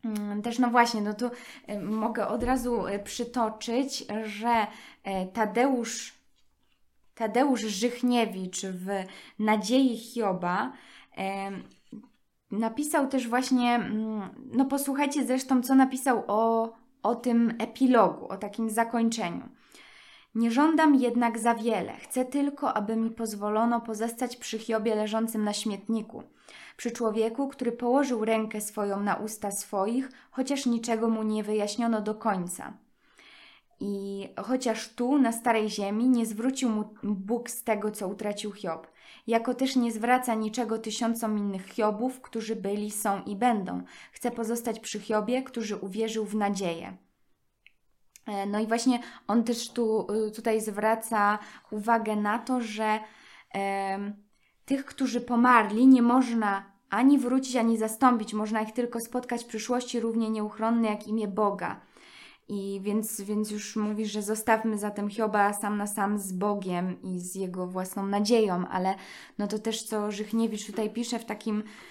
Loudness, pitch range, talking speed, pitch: -28 LUFS, 210-240 Hz, 135 wpm, 225 Hz